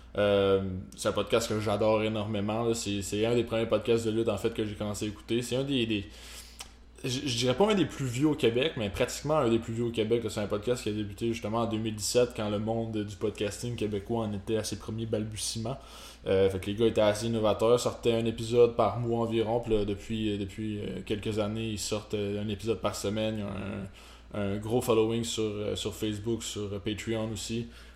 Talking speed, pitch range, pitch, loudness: 220 wpm, 105-115 Hz, 110 Hz, -30 LUFS